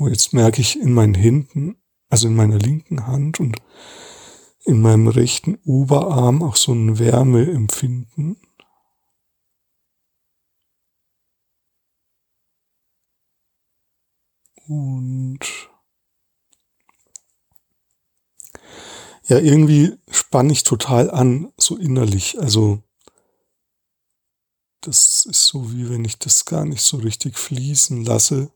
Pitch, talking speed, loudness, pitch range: 130 Hz, 90 wpm, -16 LUFS, 115-150 Hz